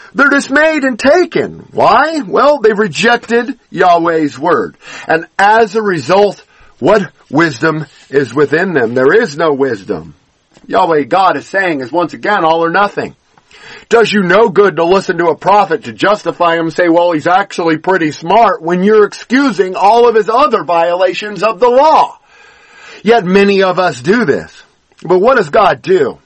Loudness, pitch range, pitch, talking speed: -11 LUFS, 170-240 Hz, 200 Hz, 170 wpm